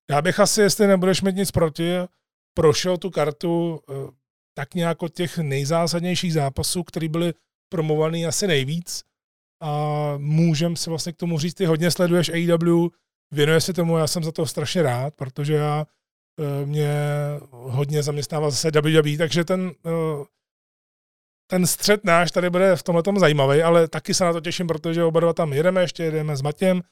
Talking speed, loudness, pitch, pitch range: 165 wpm, -21 LUFS, 165 Hz, 150-175 Hz